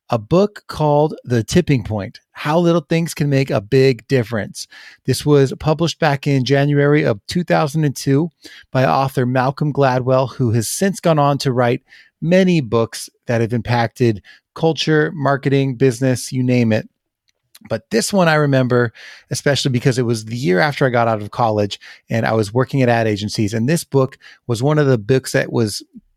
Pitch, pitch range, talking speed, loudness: 135 Hz, 120-150 Hz, 180 wpm, -17 LUFS